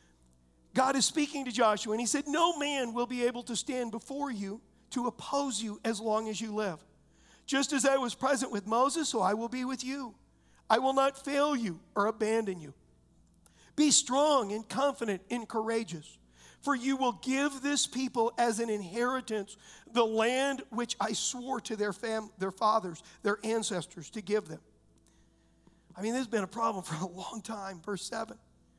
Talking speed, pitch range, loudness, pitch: 185 wpm, 200-260 Hz, -31 LUFS, 225 Hz